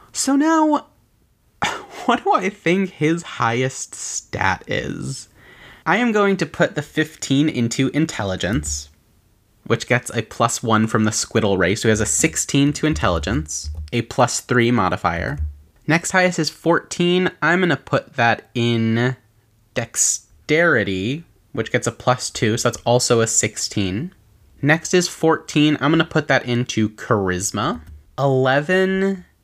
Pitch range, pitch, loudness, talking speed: 105-155 Hz, 120 Hz, -19 LUFS, 145 wpm